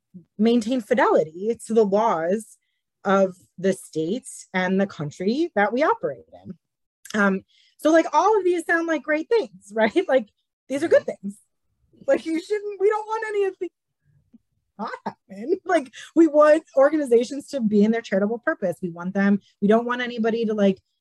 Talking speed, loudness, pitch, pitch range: 175 wpm, -22 LUFS, 240 Hz, 200-330 Hz